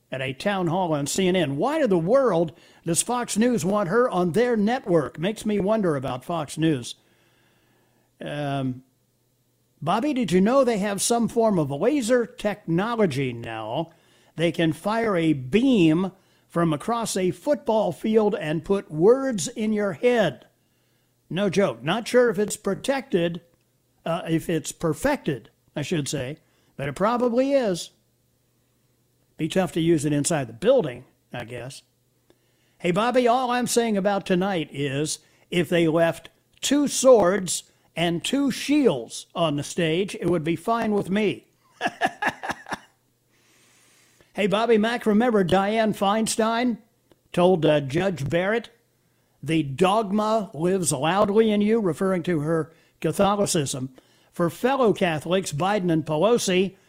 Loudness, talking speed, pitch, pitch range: -23 LUFS, 140 wpm, 180 Hz, 155-220 Hz